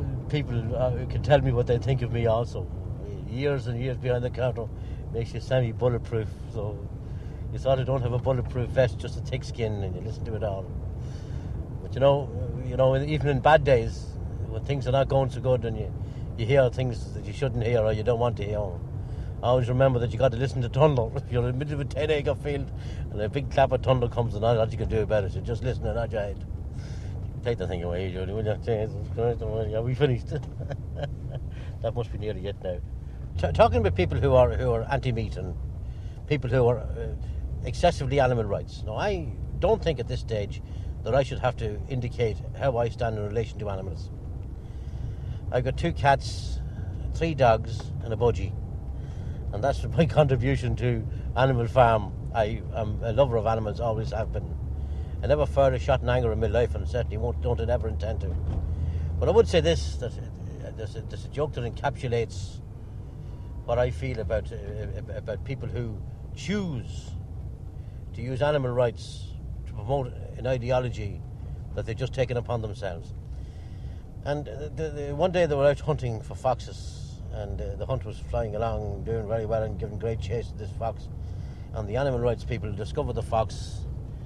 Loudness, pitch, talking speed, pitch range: -28 LUFS, 115 Hz, 195 wpm, 105-125 Hz